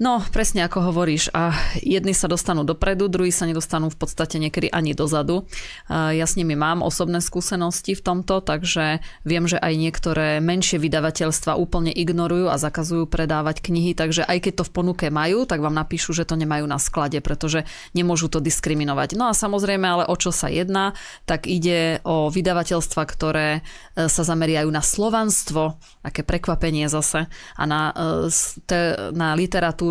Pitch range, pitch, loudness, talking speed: 155-180 Hz, 165 Hz, -21 LUFS, 165 wpm